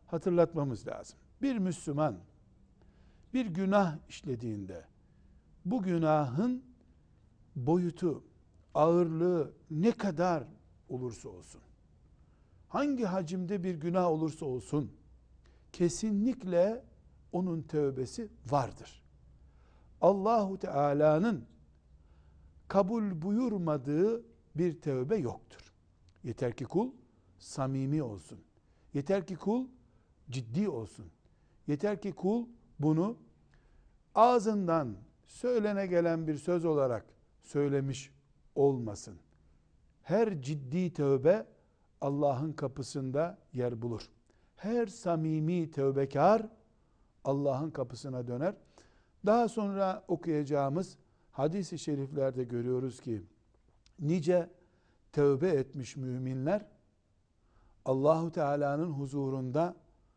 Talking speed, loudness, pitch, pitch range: 80 wpm, -32 LUFS, 145 Hz, 115-180 Hz